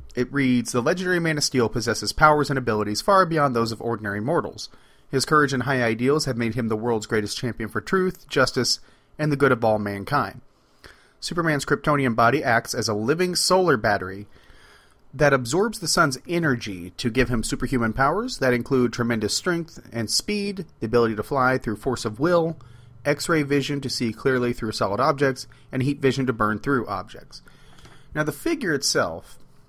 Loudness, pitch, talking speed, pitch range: -23 LUFS, 130 Hz, 185 wpm, 115-150 Hz